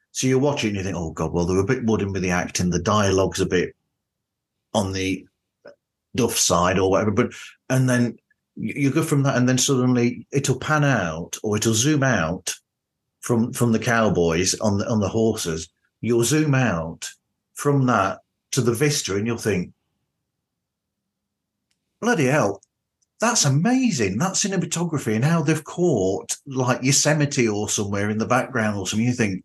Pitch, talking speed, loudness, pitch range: 120 Hz, 170 wpm, -21 LUFS, 100-140 Hz